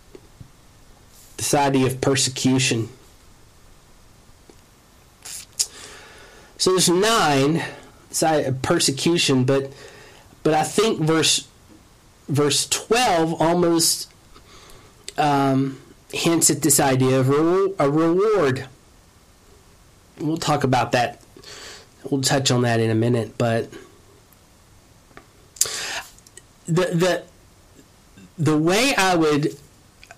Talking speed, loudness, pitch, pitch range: 85 wpm, -20 LUFS, 135 Hz, 115-160 Hz